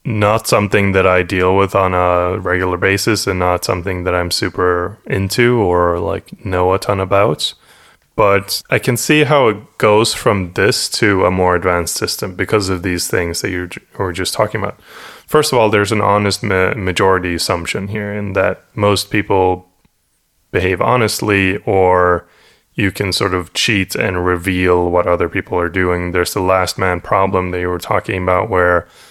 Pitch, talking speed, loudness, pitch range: 95 Hz, 180 wpm, -15 LUFS, 90-100 Hz